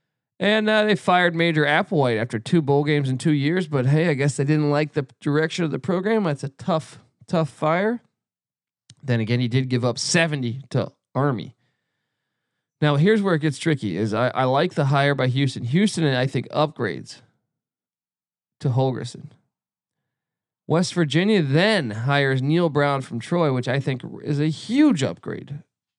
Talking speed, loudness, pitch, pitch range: 175 wpm, -21 LUFS, 150 Hz, 130-170 Hz